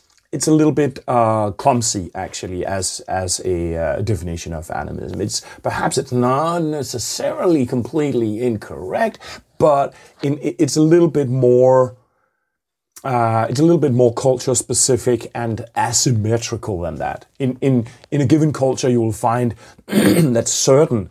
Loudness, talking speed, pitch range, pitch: -18 LUFS, 145 wpm, 115-140 Hz, 125 Hz